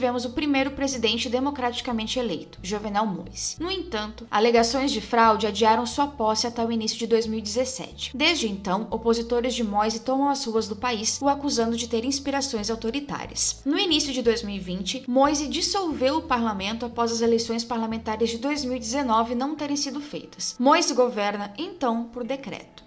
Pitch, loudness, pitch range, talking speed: 240 Hz, -24 LUFS, 225-275 Hz, 155 wpm